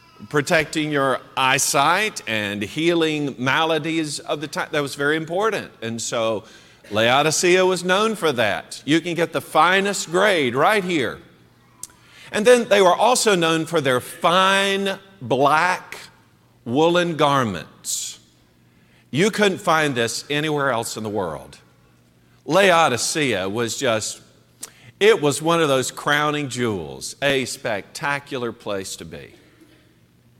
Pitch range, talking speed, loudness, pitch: 115-170 Hz, 125 wpm, -20 LUFS, 145 Hz